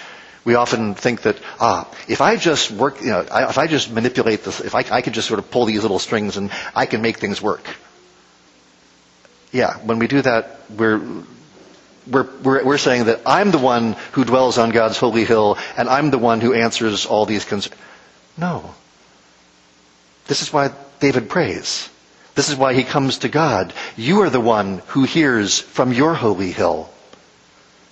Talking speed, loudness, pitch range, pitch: 180 wpm, -18 LUFS, 100-135 Hz, 115 Hz